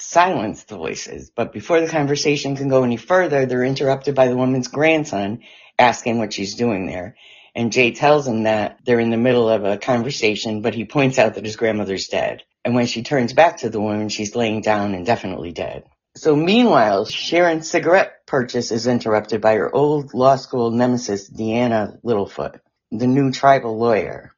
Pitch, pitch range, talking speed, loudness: 120 Hz, 110-135 Hz, 185 wpm, -18 LUFS